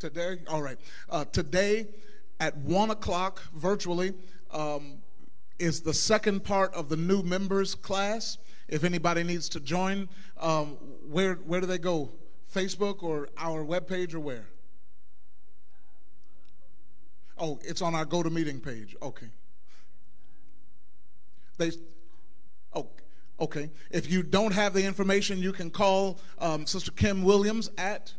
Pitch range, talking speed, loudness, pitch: 155-195 Hz, 135 wpm, -30 LUFS, 175 Hz